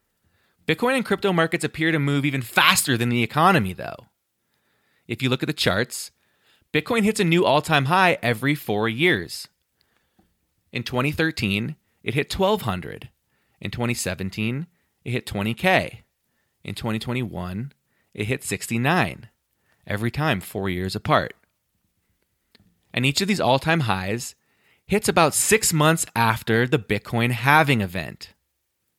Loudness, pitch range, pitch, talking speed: -22 LUFS, 110-160 Hz, 130 Hz, 135 wpm